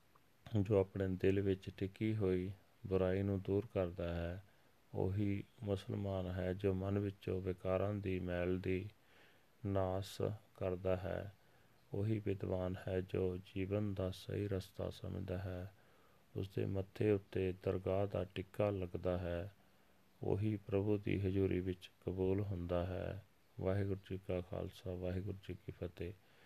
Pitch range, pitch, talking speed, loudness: 90-100 Hz, 95 Hz, 130 wpm, -41 LUFS